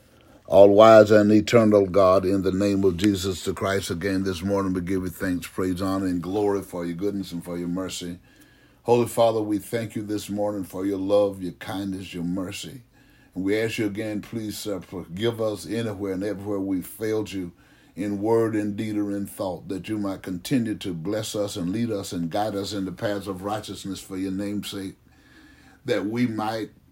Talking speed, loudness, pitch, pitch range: 200 wpm, -24 LUFS, 100 Hz, 95-105 Hz